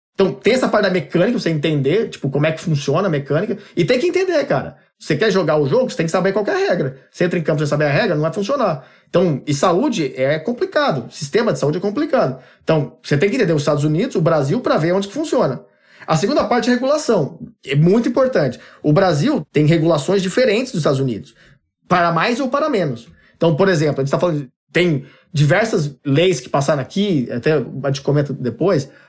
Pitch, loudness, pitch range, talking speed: 170 Hz, -17 LUFS, 150-205 Hz, 225 wpm